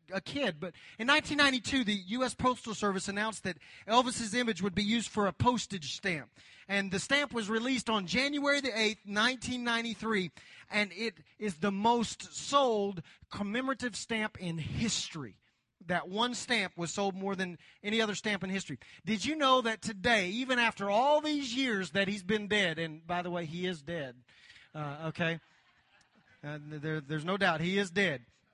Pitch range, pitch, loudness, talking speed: 175-235 Hz, 205 Hz, -32 LUFS, 175 wpm